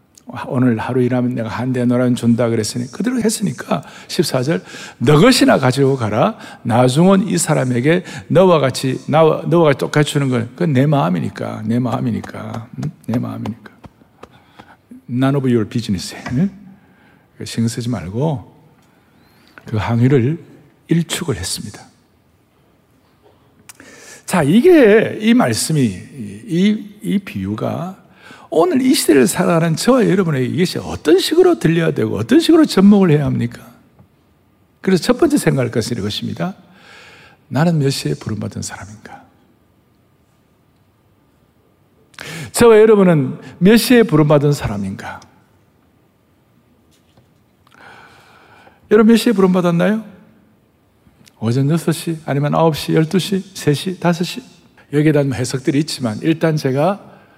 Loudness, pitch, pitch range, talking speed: -15 LUFS, 150 Hz, 125-190 Hz, 255 characters per minute